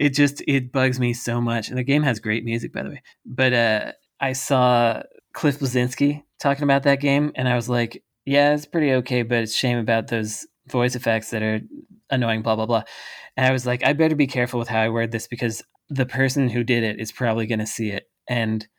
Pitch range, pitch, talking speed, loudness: 115-135 Hz, 125 Hz, 230 wpm, -22 LUFS